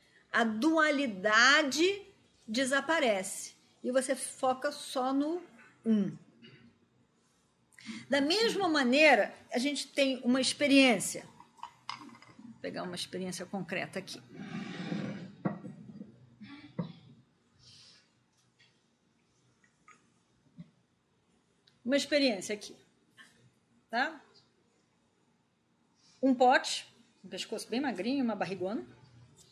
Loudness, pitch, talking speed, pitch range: -30 LUFS, 225 Hz, 70 wpm, 185-275 Hz